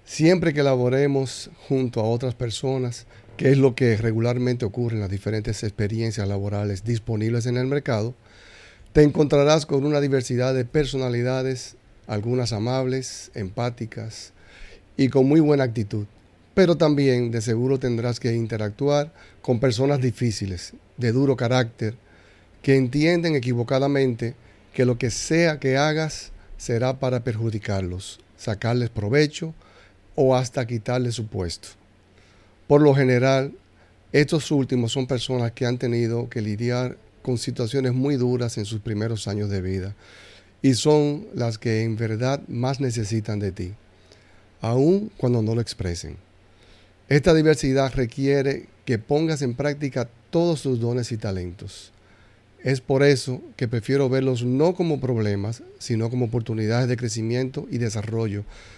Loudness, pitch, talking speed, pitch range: -23 LUFS, 120 Hz, 135 wpm, 105-135 Hz